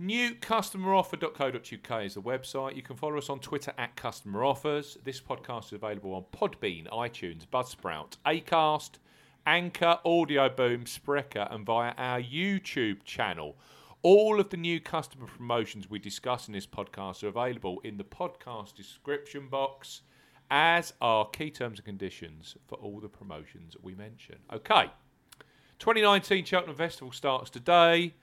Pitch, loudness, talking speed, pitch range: 135 Hz, -29 LUFS, 140 wpm, 115-170 Hz